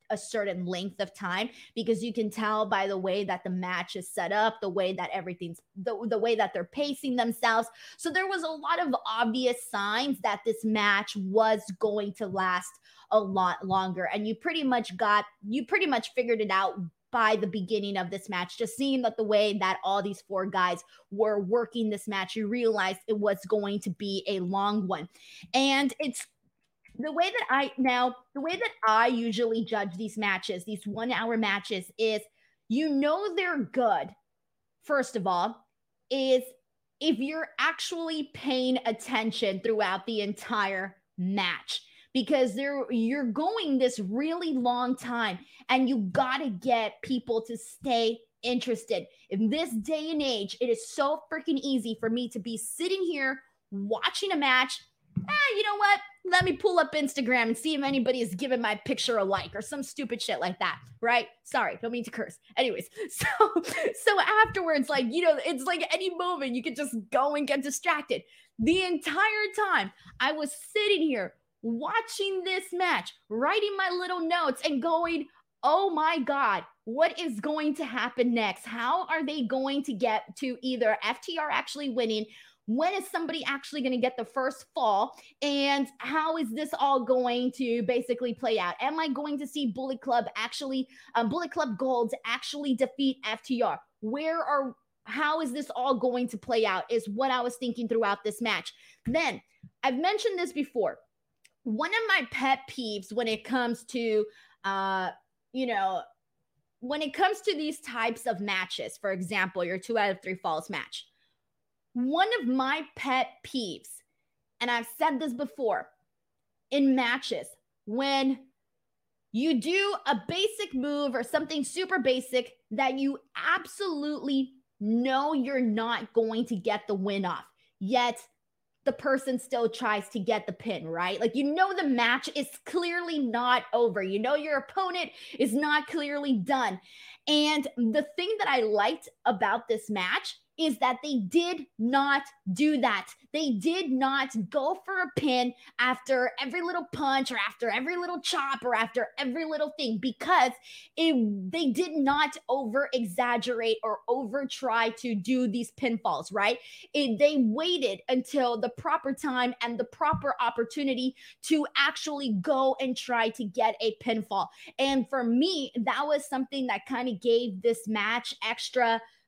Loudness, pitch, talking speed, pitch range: -29 LUFS, 250 Hz, 170 wpm, 220-290 Hz